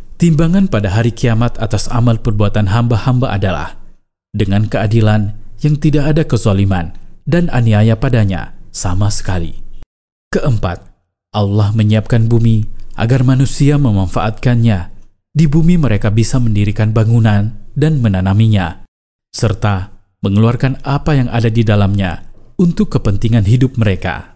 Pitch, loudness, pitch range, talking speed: 110 Hz, -14 LUFS, 105-125 Hz, 115 wpm